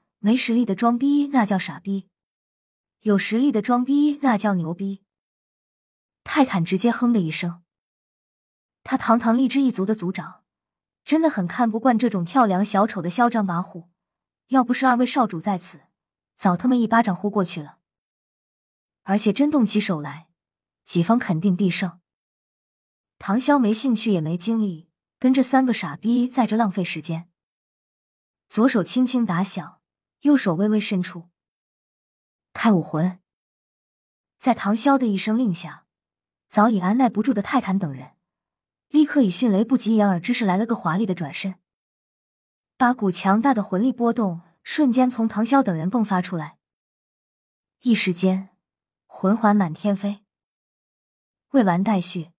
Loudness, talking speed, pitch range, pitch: -21 LUFS, 220 characters per minute, 180-245 Hz, 205 Hz